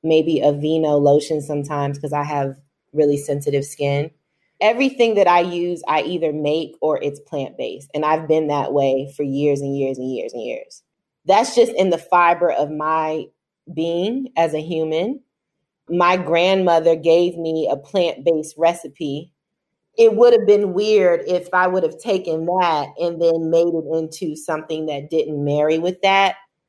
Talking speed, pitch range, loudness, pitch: 170 wpm, 150-180 Hz, -19 LUFS, 160 Hz